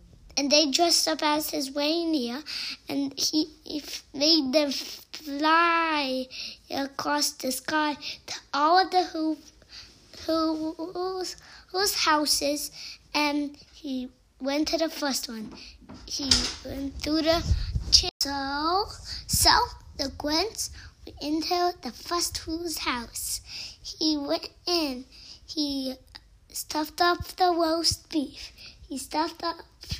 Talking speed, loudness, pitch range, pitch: 120 wpm, -26 LUFS, 285-335 Hz, 310 Hz